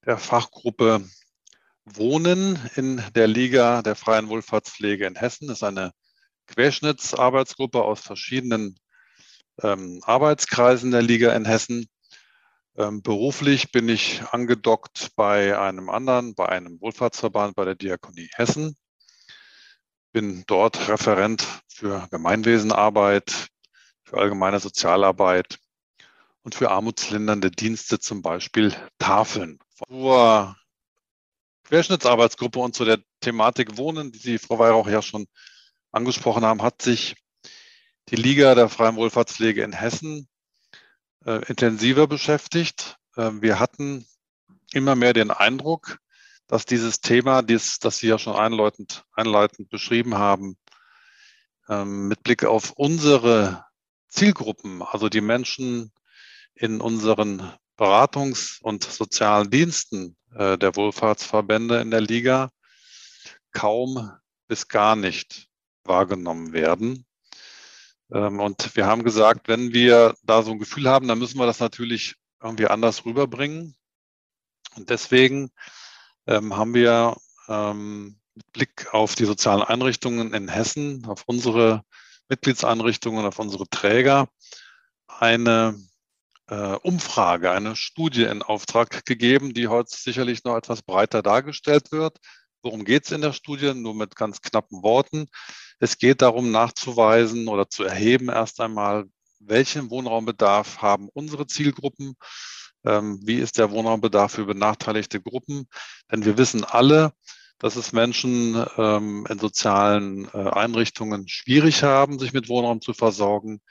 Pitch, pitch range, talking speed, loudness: 115 Hz, 105-130 Hz, 120 wpm, -21 LUFS